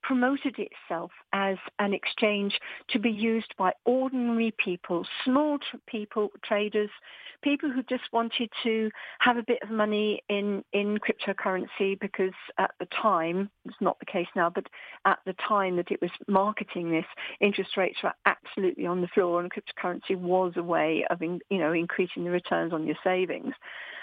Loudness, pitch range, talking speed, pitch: -28 LUFS, 180-225 Hz, 165 wpm, 200 Hz